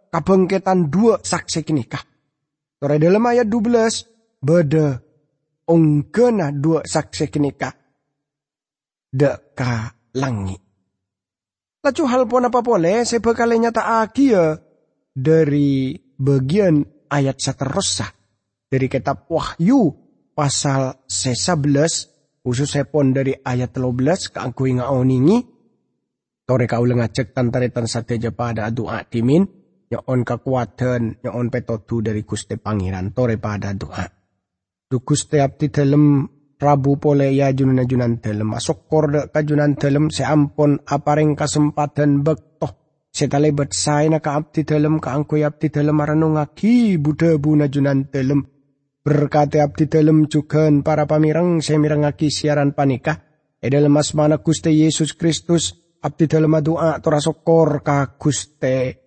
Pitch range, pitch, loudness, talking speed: 130-155 Hz, 145 Hz, -18 LUFS, 115 wpm